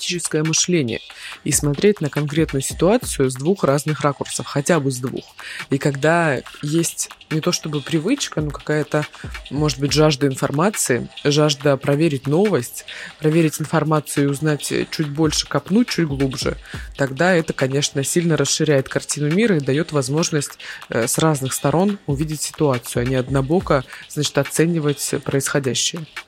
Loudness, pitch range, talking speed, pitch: -19 LUFS, 140-160 Hz, 135 wpm, 150 Hz